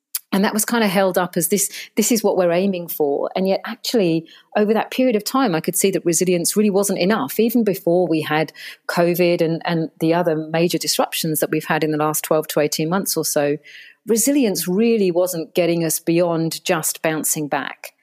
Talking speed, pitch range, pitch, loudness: 210 wpm, 160-200 Hz, 175 Hz, -19 LUFS